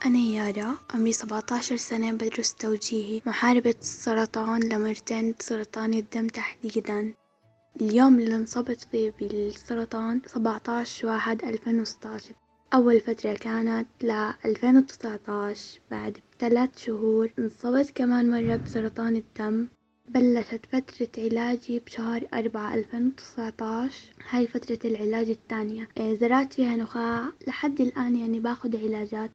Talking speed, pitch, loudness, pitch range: 105 wpm, 230 Hz, -27 LUFS, 220-240 Hz